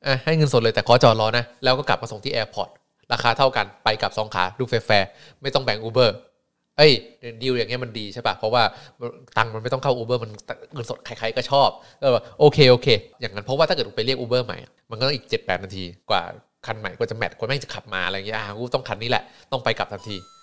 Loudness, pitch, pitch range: -21 LUFS, 120 Hz, 110-135 Hz